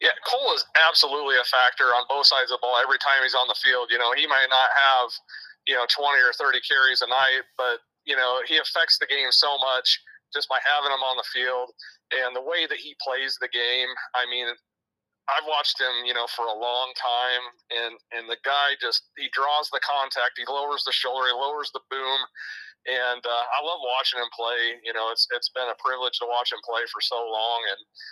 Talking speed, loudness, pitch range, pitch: 225 wpm, -23 LUFS, 120-140 Hz, 125 Hz